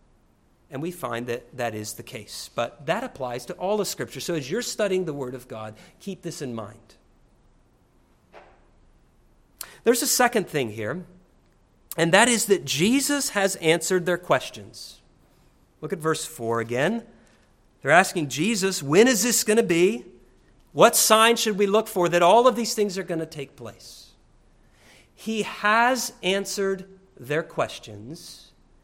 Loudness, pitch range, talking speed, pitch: -23 LUFS, 135-210 Hz, 160 wpm, 180 Hz